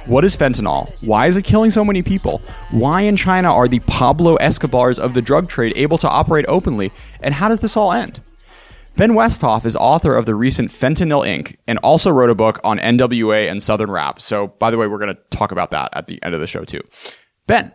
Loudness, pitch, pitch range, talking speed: -15 LUFS, 125 Hz, 110-170 Hz, 230 wpm